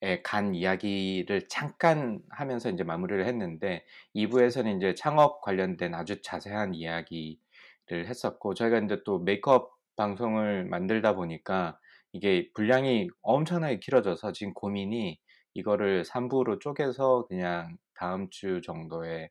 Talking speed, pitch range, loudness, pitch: 300 characters per minute, 90-125 Hz, -29 LUFS, 100 Hz